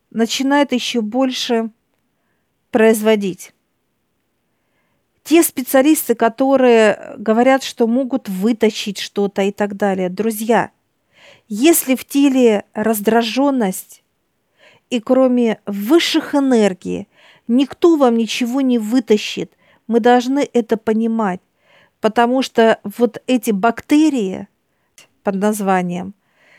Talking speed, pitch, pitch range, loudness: 90 wpm, 230 Hz, 215-265 Hz, -16 LUFS